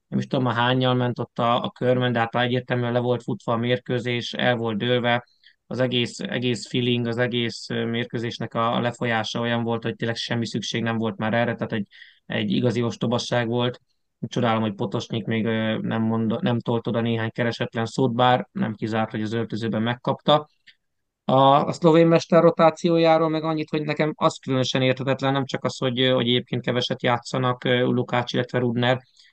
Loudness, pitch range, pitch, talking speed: -23 LUFS, 115-130 Hz, 120 Hz, 180 wpm